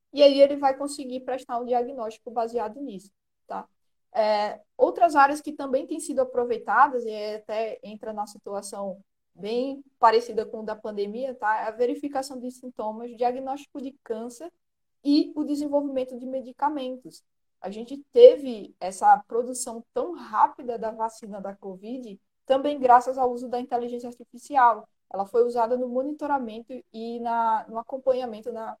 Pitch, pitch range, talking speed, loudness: 245 Hz, 225-275 Hz, 150 wpm, -25 LUFS